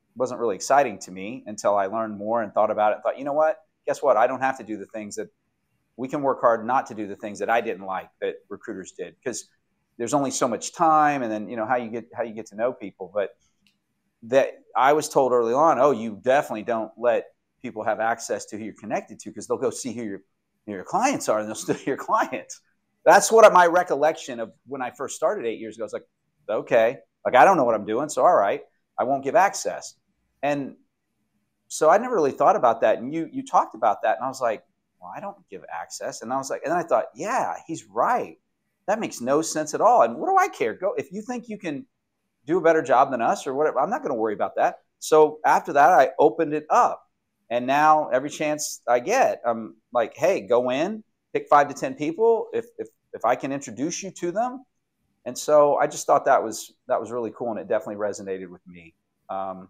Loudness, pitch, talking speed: -23 LUFS, 150 Hz, 245 wpm